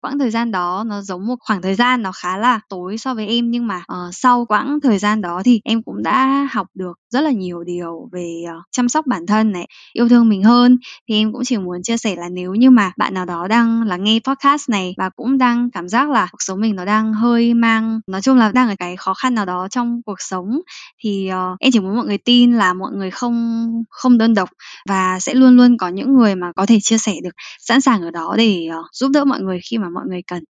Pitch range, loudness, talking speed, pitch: 185-245 Hz, -16 LUFS, 265 wpm, 220 Hz